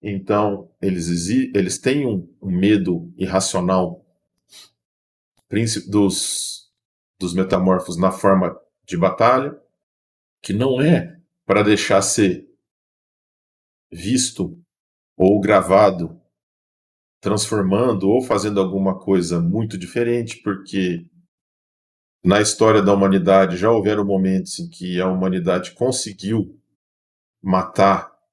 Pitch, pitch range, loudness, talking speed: 95 Hz, 90-105 Hz, -19 LUFS, 95 wpm